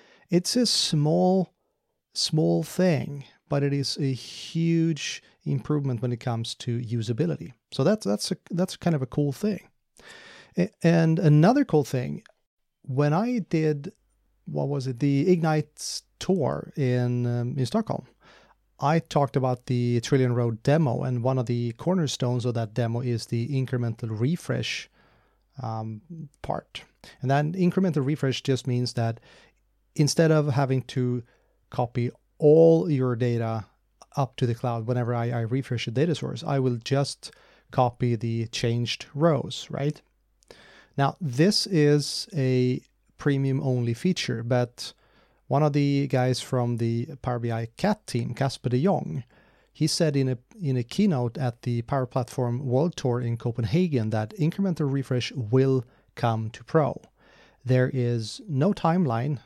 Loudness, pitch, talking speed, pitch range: -26 LUFS, 135 Hz, 145 wpm, 120-155 Hz